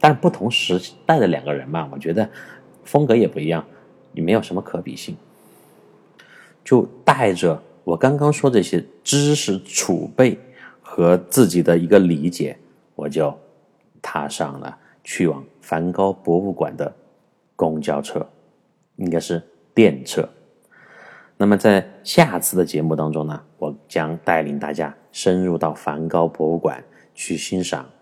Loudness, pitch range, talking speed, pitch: -20 LUFS, 80-95 Hz, 210 characters per minute, 85 Hz